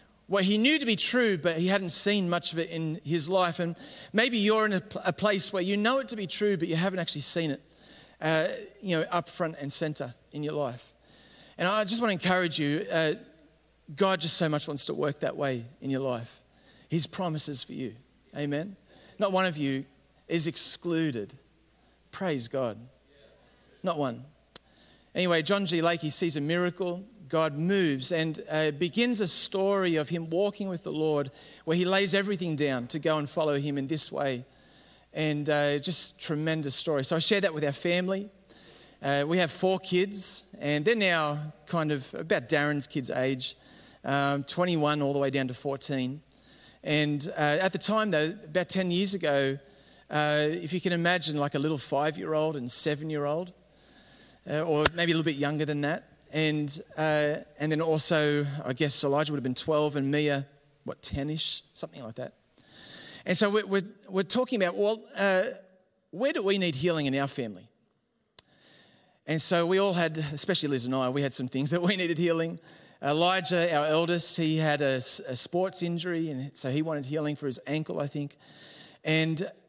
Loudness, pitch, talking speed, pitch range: -28 LUFS, 160 Hz, 185 wpm, 145-180 Hz